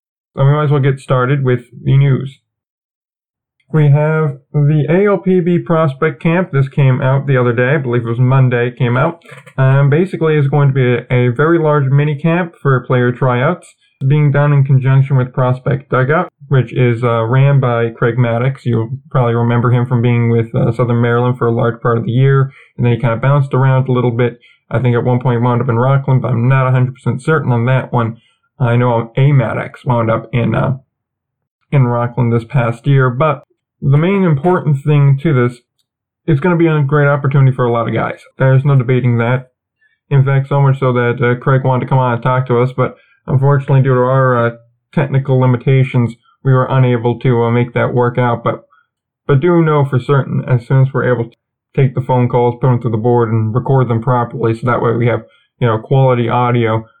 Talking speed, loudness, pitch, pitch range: 220 wpm, -13 LUFS, 130 Hz, 120-140 Hz